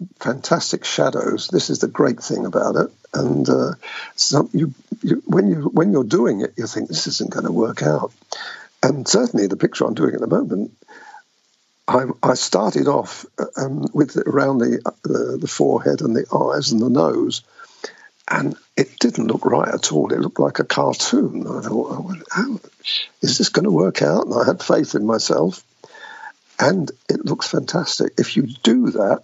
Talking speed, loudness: 185 wpm, -19 LUFS